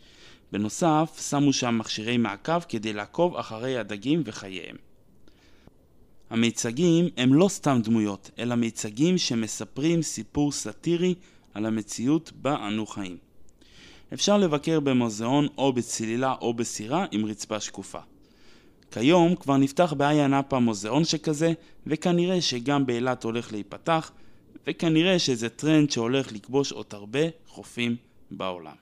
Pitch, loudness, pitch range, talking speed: 130 Hz, -25 LUFS, 110-160 Hz, 115 wpm